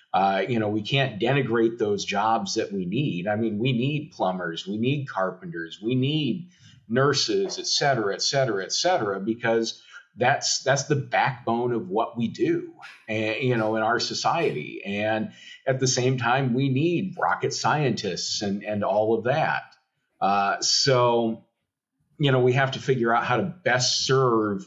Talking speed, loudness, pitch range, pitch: 170 wpm, -24 LUFS, 110-135 Hz, 120 Hz